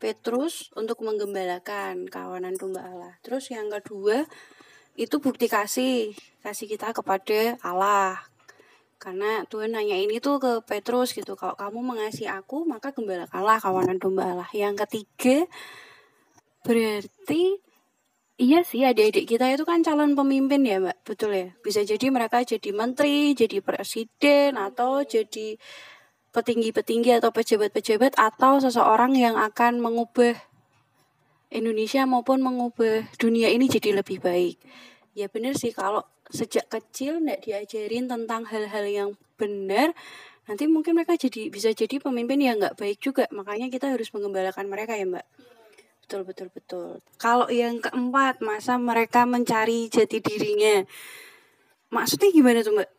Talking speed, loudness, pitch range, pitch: 135 wpm, -24 LUFS, 205-260 Hz, 225 Hz